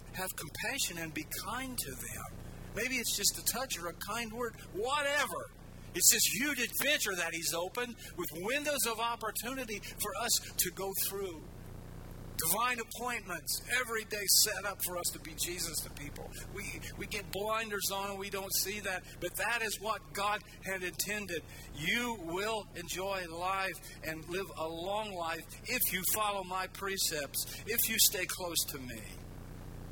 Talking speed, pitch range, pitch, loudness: 165 wpm, 165-220 Hz, 190 Hz, -33 LUFS